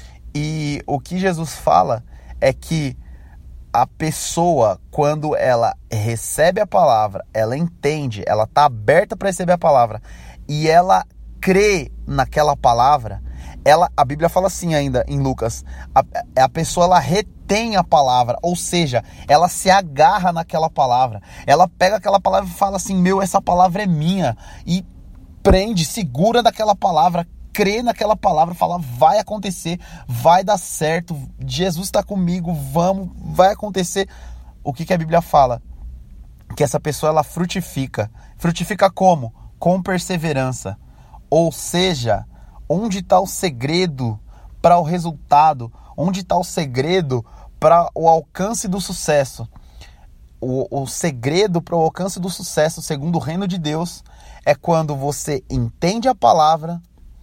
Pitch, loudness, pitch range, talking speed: 165 Hz, -18 LUFS, 130-185 Hz, 140 wpm